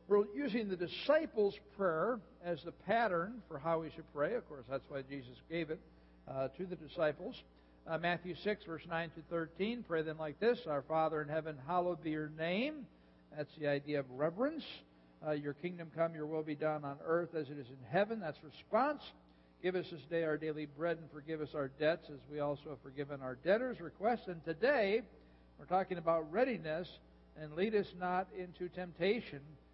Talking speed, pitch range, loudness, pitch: 195 wpm, 145-180 Hz, -39 LUFS, 160 Hz